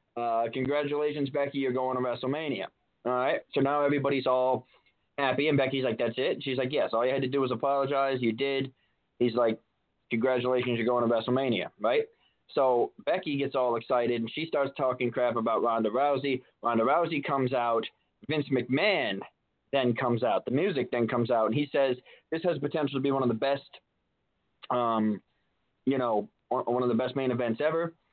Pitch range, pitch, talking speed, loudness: 120-140 Hz, 130 Hz, 190 wpm, -29 LUFS